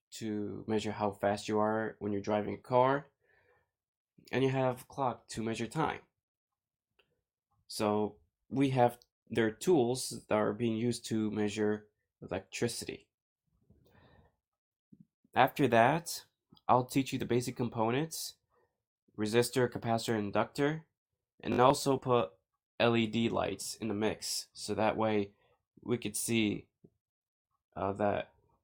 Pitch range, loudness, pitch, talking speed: 105-125 Hz, -33 LUFS, 115 Hz, 120 wpm